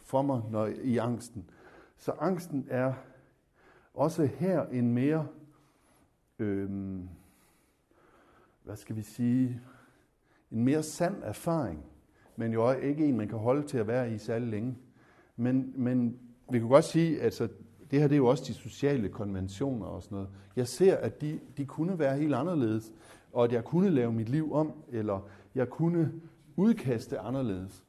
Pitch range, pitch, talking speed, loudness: 110-145 Hz, 125 Hz, 165 wpm, -31 LUFS